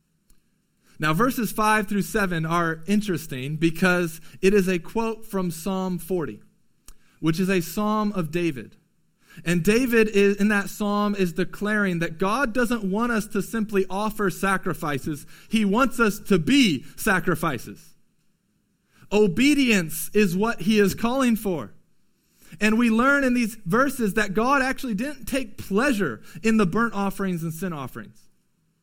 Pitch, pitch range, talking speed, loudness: 200 Hz, 175-220 Hz, 145 wpm, -23 LUFS